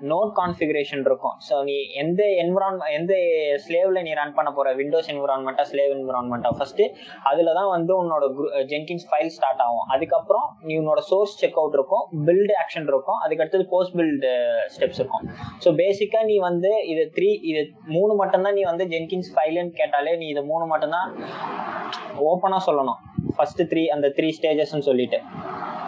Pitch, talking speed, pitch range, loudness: 170 Hz, 160 wpm, 150-195 Hz, -22 LUFS